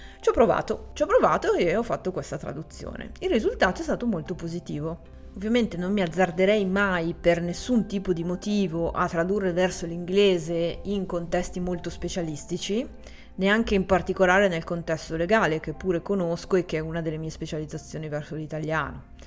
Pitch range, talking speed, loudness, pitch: 165-200 Hz, 165 wpm, -26 LUFS, 180 Hz